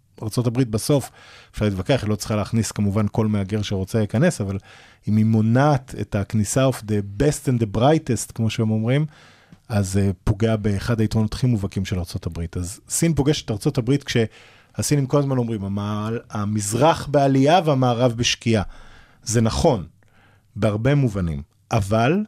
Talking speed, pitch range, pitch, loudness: 150 wpm, 105-130 Hz, 110 Hz, -21 LUFS